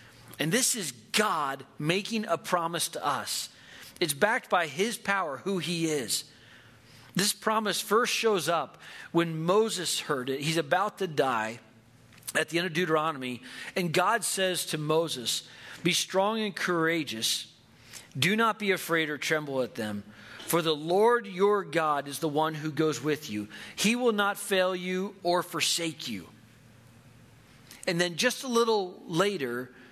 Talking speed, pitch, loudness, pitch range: 155 wpm, 165 Hz, -28 LUFS, 130-190 Hz